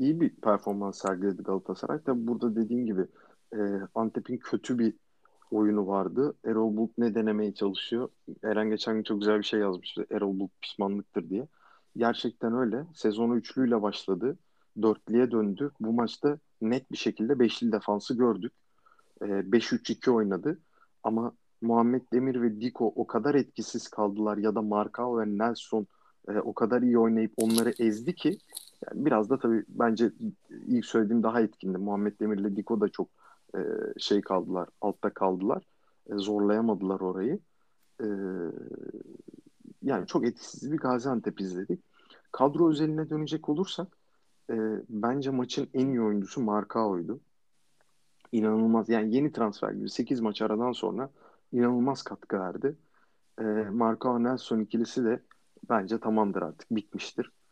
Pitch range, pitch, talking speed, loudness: 105-125 Hz, 115 Hz, 135 wpm, -29 LUFS